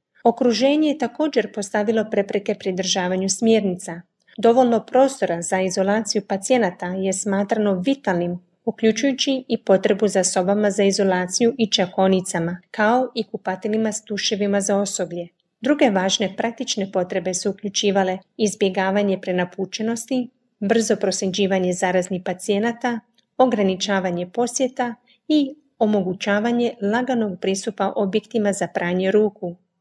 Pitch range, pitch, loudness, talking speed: 190-230 Hz, 205 Hz, -21 LUFS, 105 wpm